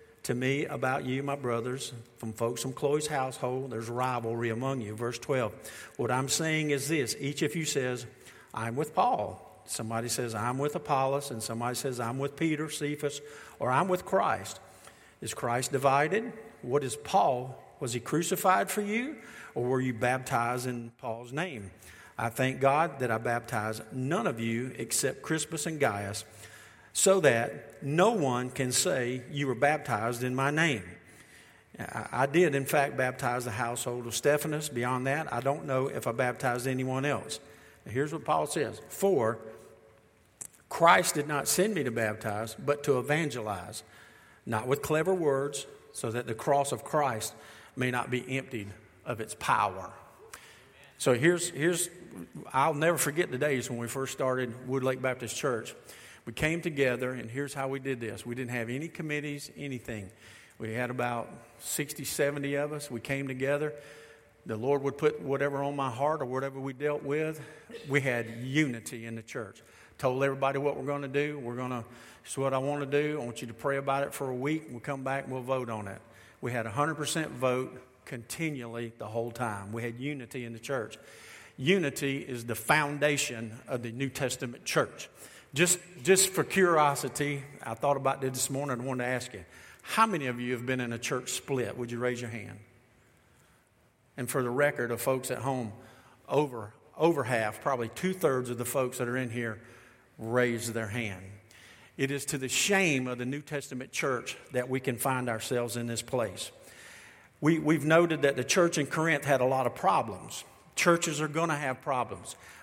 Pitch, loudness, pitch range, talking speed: 130 Hz, -30 LUFS, 120-145 Hz, 185 wpm